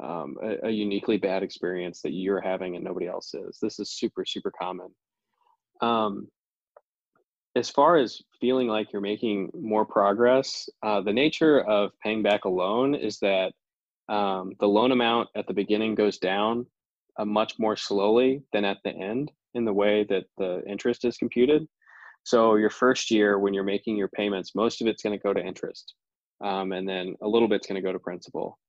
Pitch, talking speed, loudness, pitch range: 105 Hz, 185 wpm, -26 LUFS, 100-120 Hz